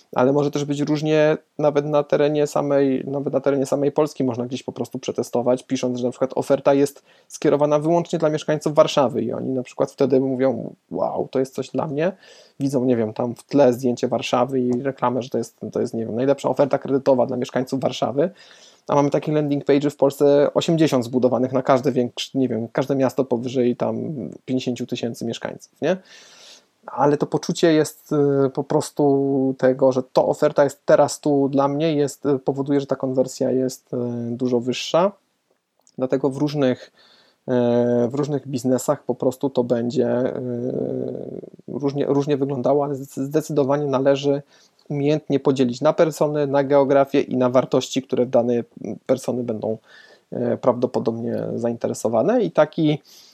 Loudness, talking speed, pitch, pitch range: -21 LUFS, 160 wpm, 135 Hz, 125-145 Hz